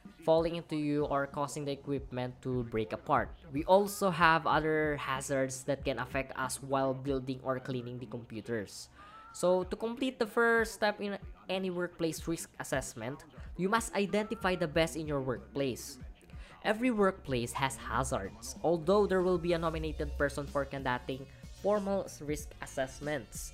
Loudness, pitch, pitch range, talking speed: -33 LUFS, 150 Hz, 135-185 Hz, 155 wpm